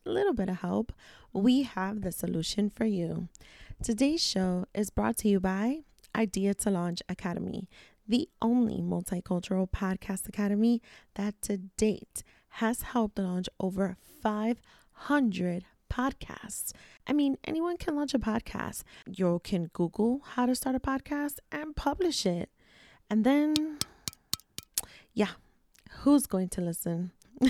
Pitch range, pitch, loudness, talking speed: 185-260 Hz, 210 Hz, -31 LUFS, 130 wpm